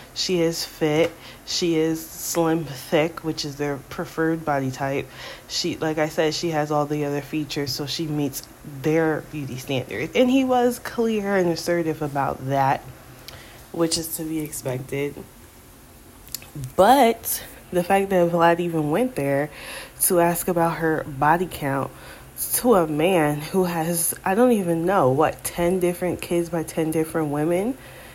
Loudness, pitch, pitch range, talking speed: -23 LUFS, 160 Hz, 145-175 Hz, 155 wpm